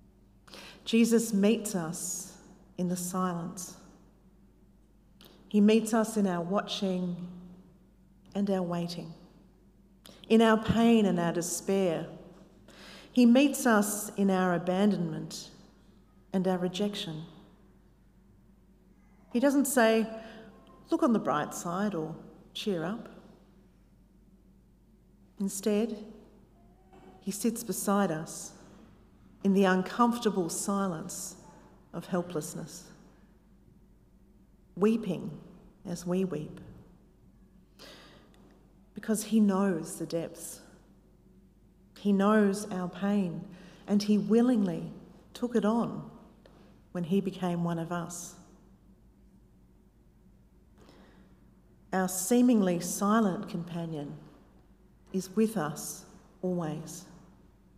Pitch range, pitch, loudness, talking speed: 180-210 Hz, 190 Hz, -29 LUFS, 90 wpm